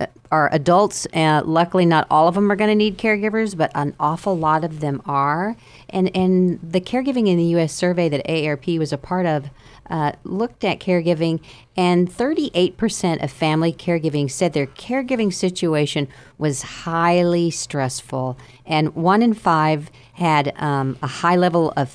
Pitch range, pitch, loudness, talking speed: 150-185 Hz, 165 Hz, -19 LUFS, 165 wpm